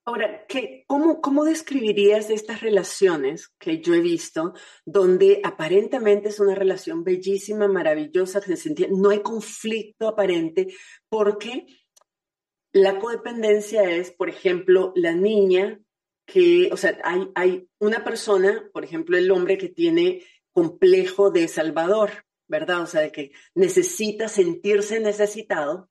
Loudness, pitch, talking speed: -21 LUFS, 215 Hz, 130 wpm